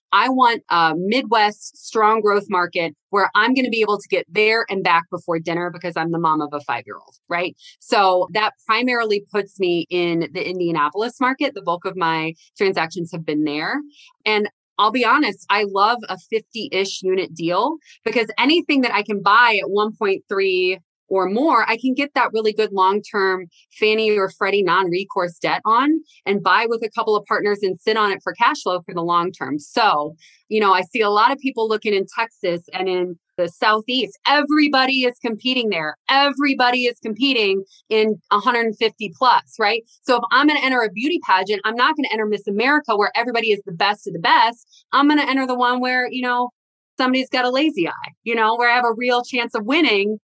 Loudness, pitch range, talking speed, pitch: -19 LUFS, 185-245 Hz, 210 wpm, 210 Hz